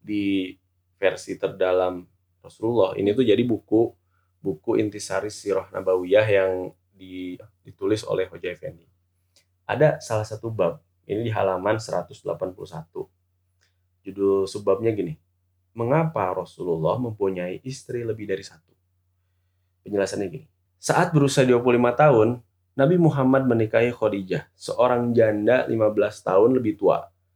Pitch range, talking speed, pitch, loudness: 90-115 Hz, 115 wpm, 100 Hz, -23 LUFS